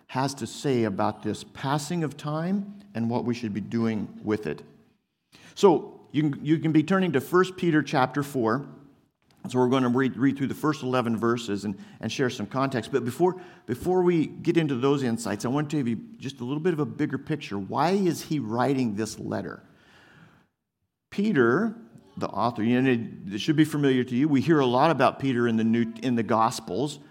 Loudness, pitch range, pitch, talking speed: -26 LUFS, 115-155 Hz, 135 Hz, 205 wpm